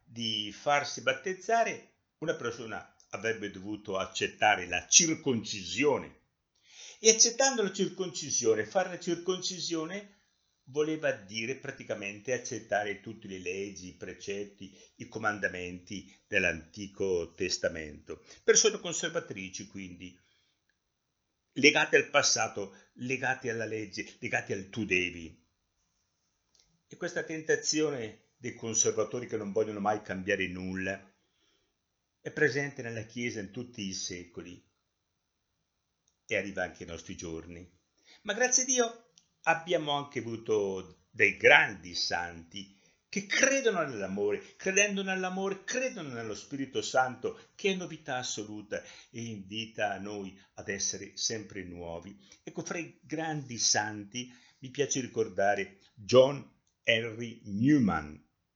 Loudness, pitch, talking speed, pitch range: -30 LUFS, 115 Hz, 115 wpm, 100-160 Hz